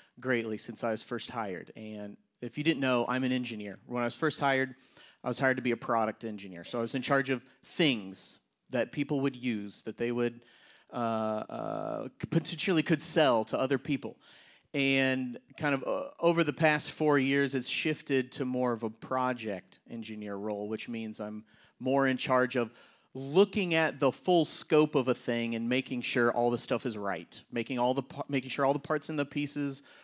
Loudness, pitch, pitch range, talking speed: -31 LUFS, 130 Hz, 115-140 Hz, 200 wpm